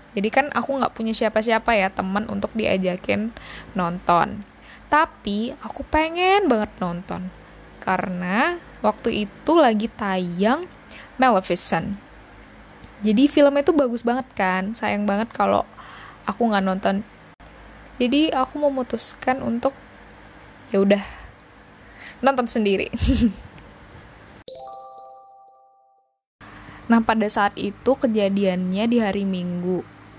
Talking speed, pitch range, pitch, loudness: 100 wpm, 185-250 Hz, 210 Hz, -22 LUFS